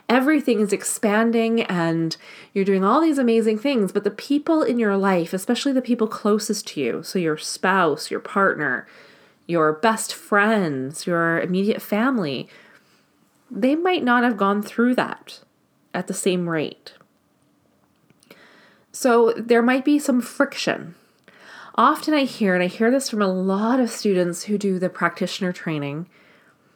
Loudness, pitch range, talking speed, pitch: -21 LUFS, 185-245 Hz, 150 wpm, 210 Hz